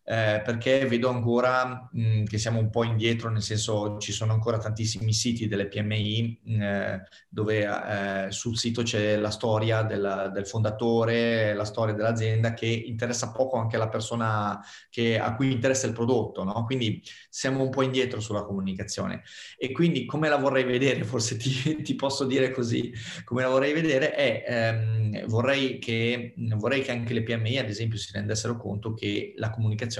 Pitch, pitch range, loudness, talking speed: 115 Hz, 110-125 Hz, -27 LUFS, 170 wpm